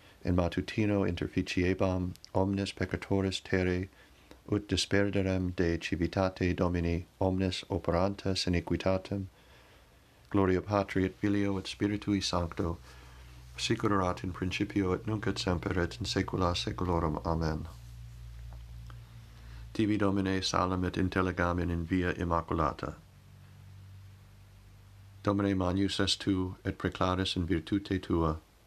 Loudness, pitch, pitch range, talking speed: -31 LUFS, 95 Hz, 85-100 Hz, 105 wpm